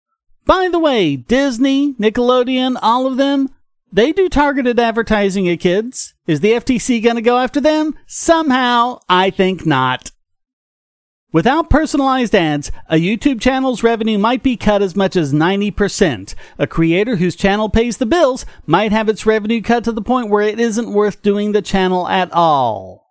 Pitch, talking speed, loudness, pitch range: 230 Hz, 165 wpm, -15 LUFS, 195-260 Hz